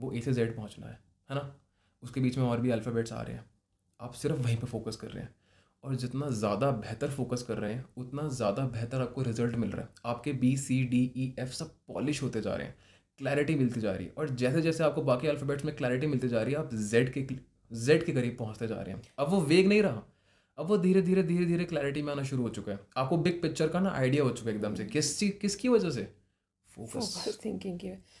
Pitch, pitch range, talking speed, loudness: 130 Hz, 115-150 Hz, 250 wpm, -31 LUFS